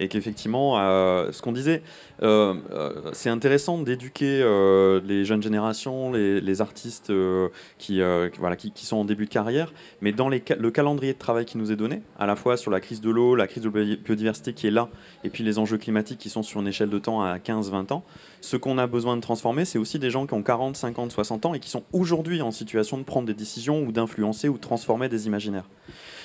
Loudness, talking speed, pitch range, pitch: -25 LUFS, 240 wpm, 105-130 Hz, 115 Hz